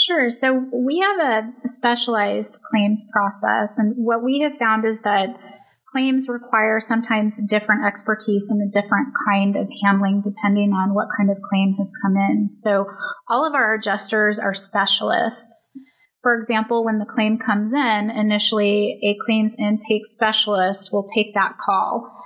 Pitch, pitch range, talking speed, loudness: 215 Hz, 205-235 Hz, 155 wpm, -19 LUFS